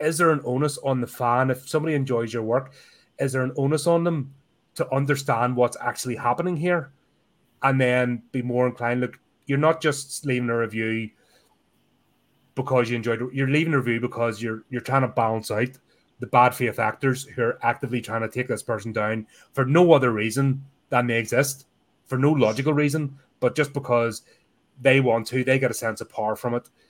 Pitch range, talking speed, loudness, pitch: 120-140 Hz, 200 wpm, -24 LUFS, 125 Hz